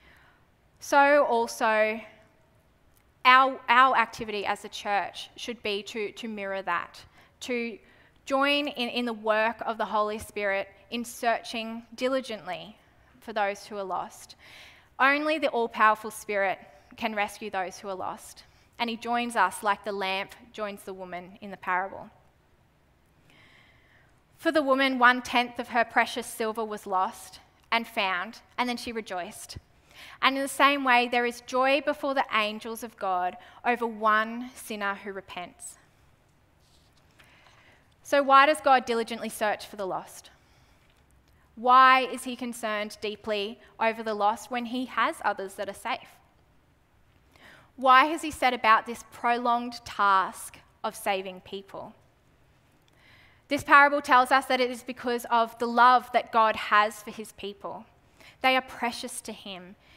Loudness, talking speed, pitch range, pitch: -26 LUFS, 150 wpm, 210-250 Hz, 230 Hz